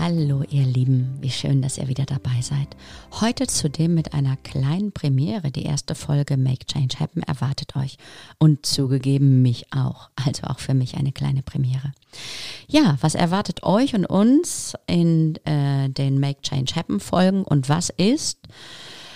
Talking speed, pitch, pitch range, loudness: 160 wpm, 140 Hz, 135-160 Hz, -22 LUFS